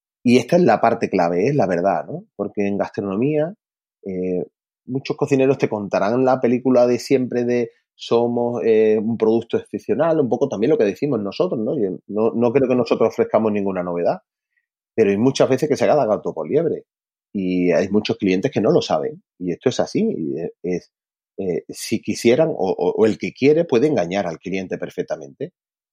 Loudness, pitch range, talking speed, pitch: -19 LUFS, 100-130 Hz, 185 wpm, 115 Hz